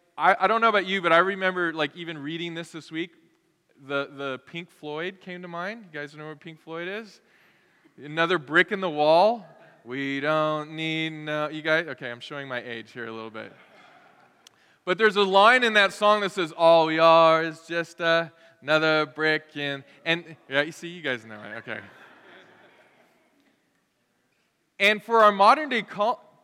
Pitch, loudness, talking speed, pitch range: 165 Hz, -23 LUFS, 185 wpm, 150-185 Hz